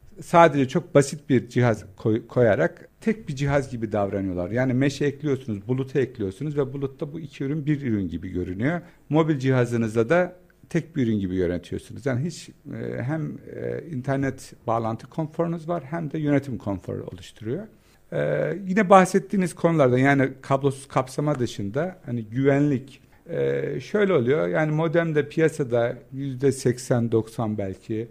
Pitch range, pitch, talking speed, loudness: 115-160 Hz, 135 Hz, 130 wpm, -24 LUFS